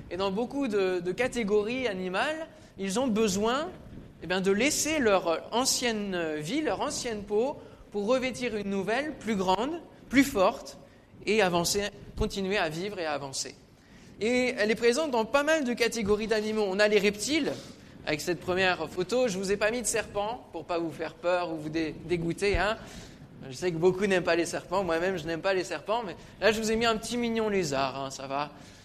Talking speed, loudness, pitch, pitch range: 210 wpm, -28 LUFS, 205 Hz, 175-230 Hz